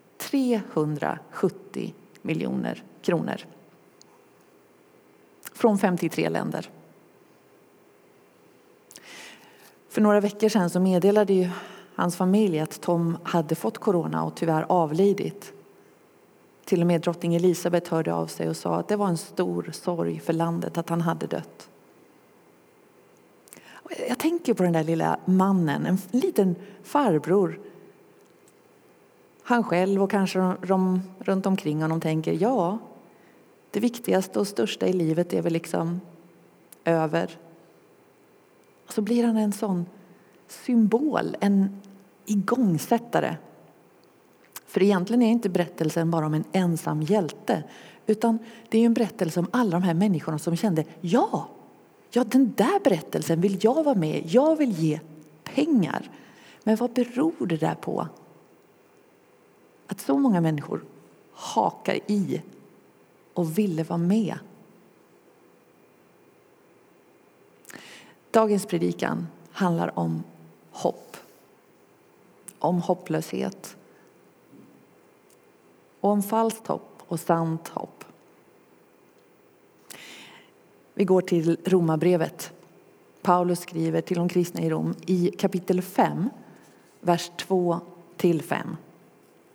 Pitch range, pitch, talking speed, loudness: 165-210 Hz, 185 Hz, 110 wpm, -25 LUFS